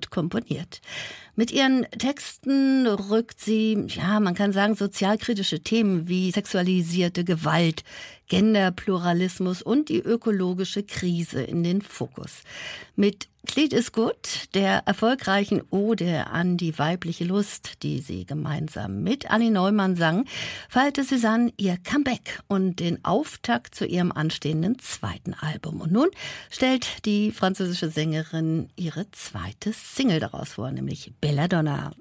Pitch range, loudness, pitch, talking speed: 170-220 Hz, -25 LUFS, 195 Hz, 125 wpm